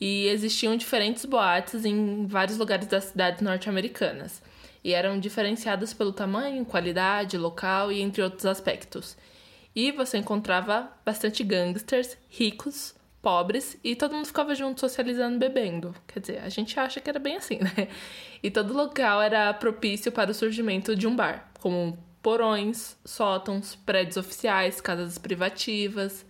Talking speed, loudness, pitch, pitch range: 145 wpm, -27 LUFS, 210 Hz, 195-230 Hz